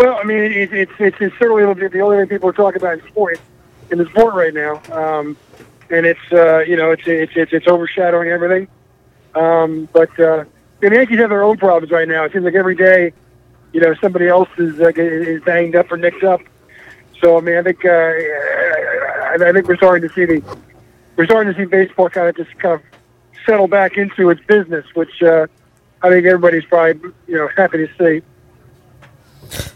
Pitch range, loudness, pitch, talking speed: 160-185 Hz, -14 LUFS, 170 Hz, 205 wpm